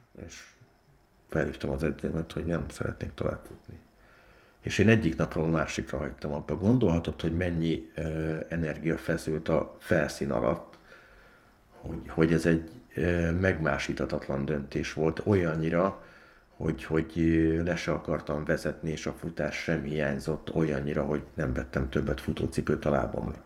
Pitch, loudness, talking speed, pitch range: 80 Hz, -30 LUFS, 135 wpm, 75-85 Hz